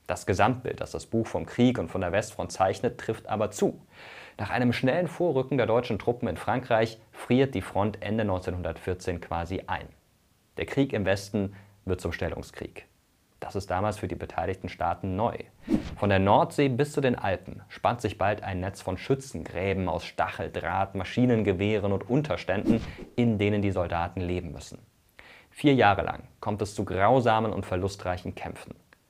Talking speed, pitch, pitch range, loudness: 165 wpm, 100 Hz, 95-115 Hz, -28 LUFS